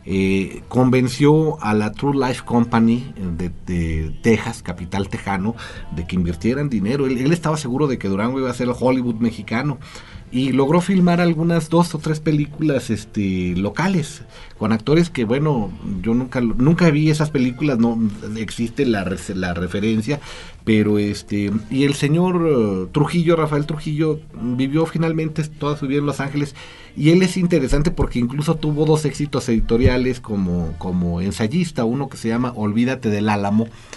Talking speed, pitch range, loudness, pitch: 160 wpm, 105-150 Hz, -20 LUFS, 125 Hz